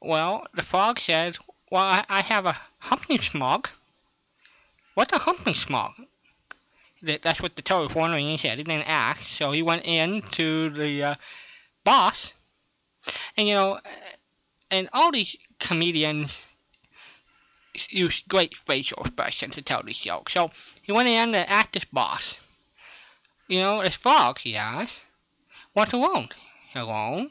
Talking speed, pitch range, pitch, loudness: 145 wpm, 160-210 Hz, 175 Hz, -24 LUFS